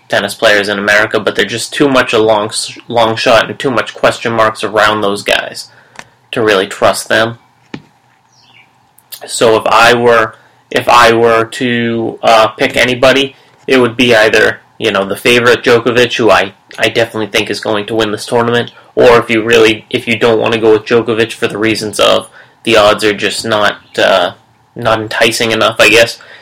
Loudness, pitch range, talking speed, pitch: -10 LUFS, 110-120 Hz, 190 wpm, 115 Hz